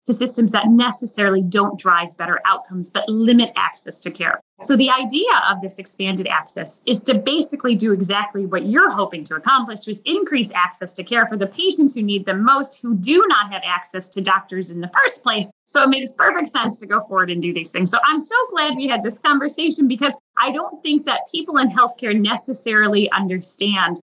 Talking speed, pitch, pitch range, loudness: 210 wpm, 220 Hz, 190-270 Hz, -18 LUFS